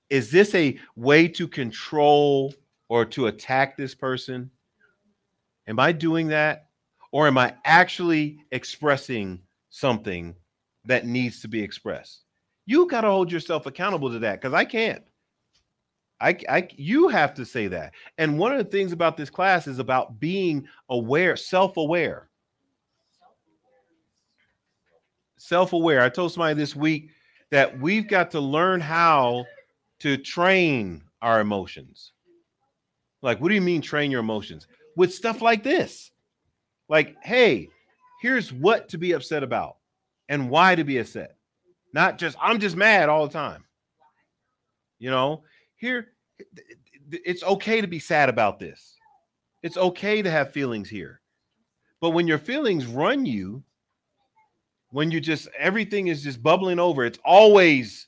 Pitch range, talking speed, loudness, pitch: 130-185 Hz, 145 wpm, -22 LUFS, 155 Hz